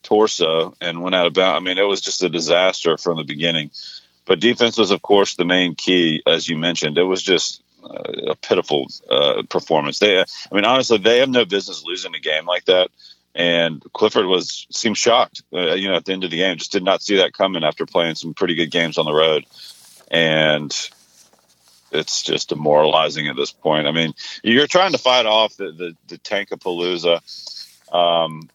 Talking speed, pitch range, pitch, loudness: 205 wpm, 80-100 Hz, 85 Hz, -18 LUFS